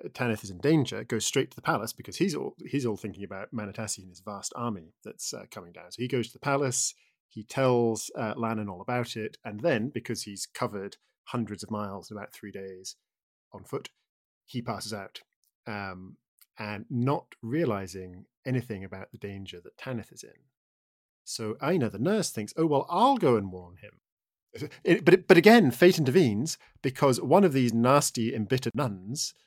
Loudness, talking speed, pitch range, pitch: -27 LUFS, 185 wpm, 100-130 Hz, 115 Hz